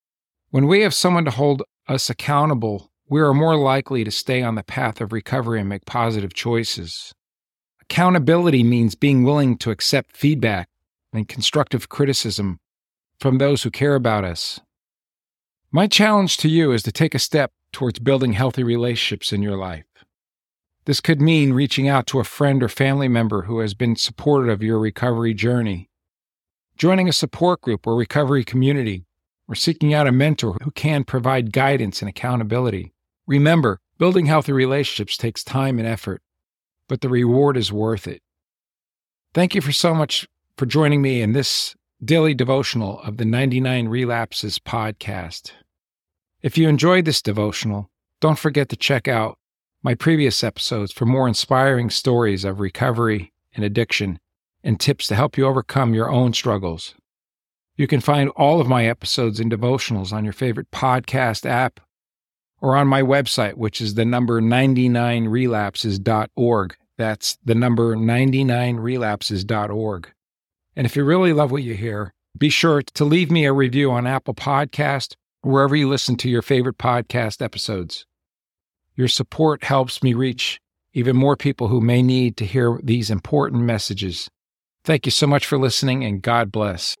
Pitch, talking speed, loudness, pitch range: 125 Hz, 160 wpm, -19 LUFS, 110-140 Hz